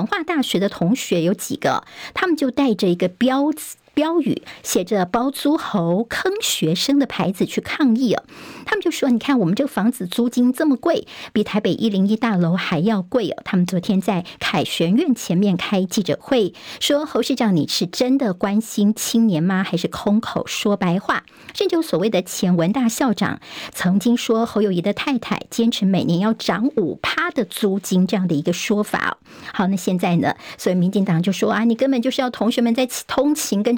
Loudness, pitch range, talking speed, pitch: -20 LUFS, 190-260 Hz, 290 characters per minute, 220 Hz